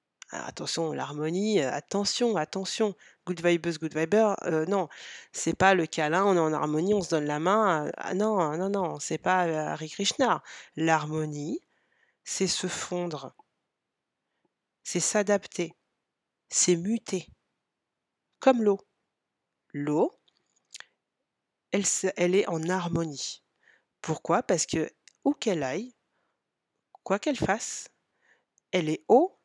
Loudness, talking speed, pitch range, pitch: -28 LUFS, 120 wpm, 160-200 Hz, 180 Hz